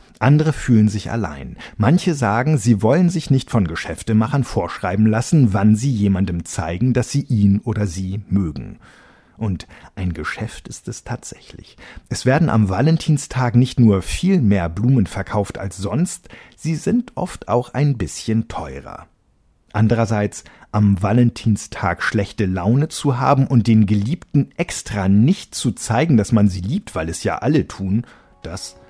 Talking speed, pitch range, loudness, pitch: 150 wpm, 100-130 Hz, -18 LUFS, 110 Hz